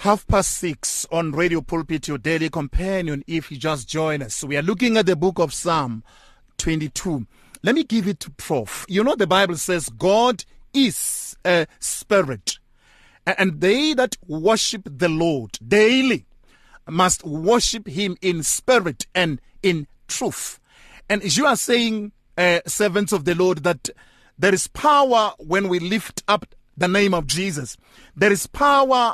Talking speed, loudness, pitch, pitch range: 165 wpm, -20 LUFS, 180 Hz, 160-210 Hz